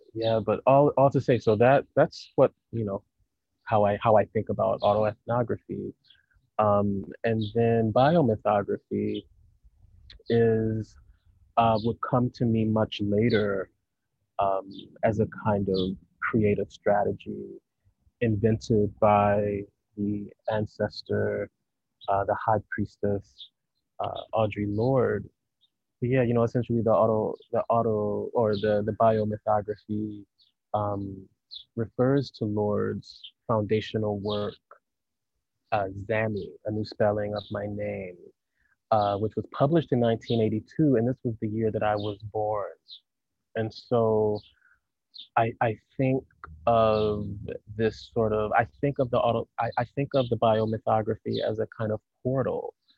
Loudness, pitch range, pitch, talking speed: -27 LUFS, 105-115 Hz, 110 Hz, 130 wpm